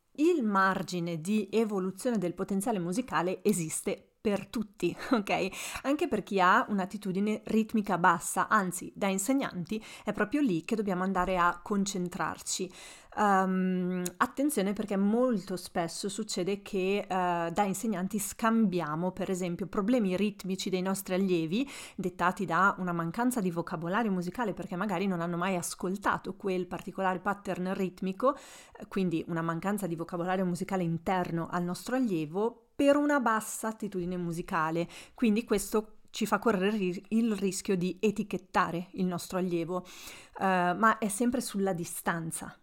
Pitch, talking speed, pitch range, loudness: 190 Hz, 135 wpm, 180-215 Hz, -31 LUFS